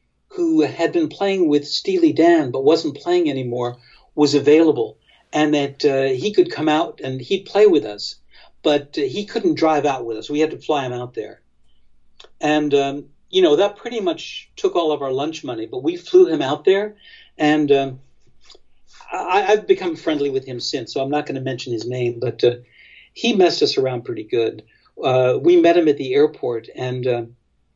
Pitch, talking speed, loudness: 150 Hz, 200 wpm, -19 LUFS